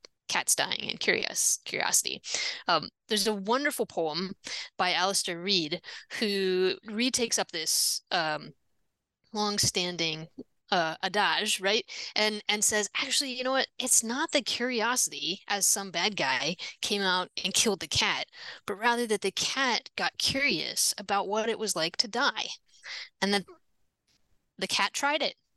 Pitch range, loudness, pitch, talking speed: 185-230 Hz, -28 LUFS, 205 Hz, 150 wpm